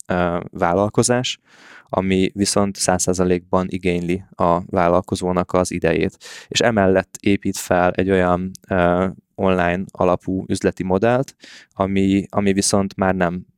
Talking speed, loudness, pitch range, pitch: 115 wpm, -19 LUFS, 90-100 Hz, 95 Hz